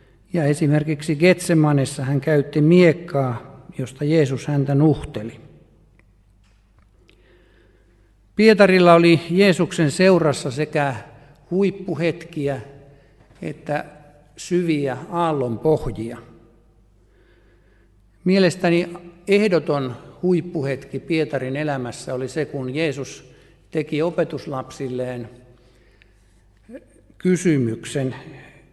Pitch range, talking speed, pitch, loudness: 120-165 Hz, 65 wpm, 145 Hz, -20 LUFS